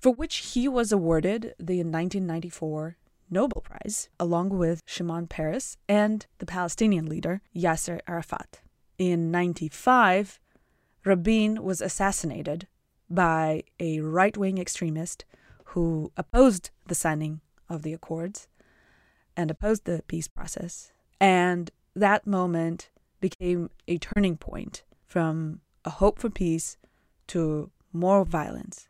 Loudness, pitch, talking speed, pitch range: -27 LUFS, 175 Hz, 115 wpm, 165-195 Hz